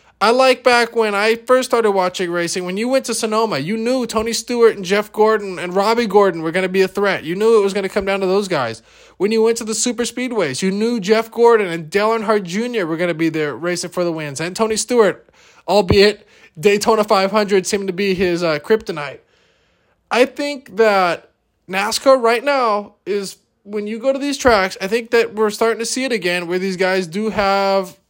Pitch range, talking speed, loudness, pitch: 190-230 Hz, 220 wpm, -17 LUFS, 210 Hz